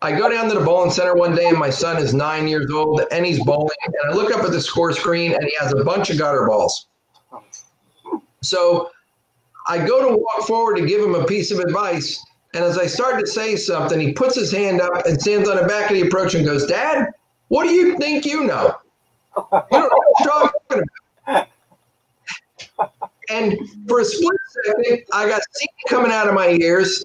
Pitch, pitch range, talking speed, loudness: 190 Hz, 170-240 Hz, 210 wpm, -18 LUFS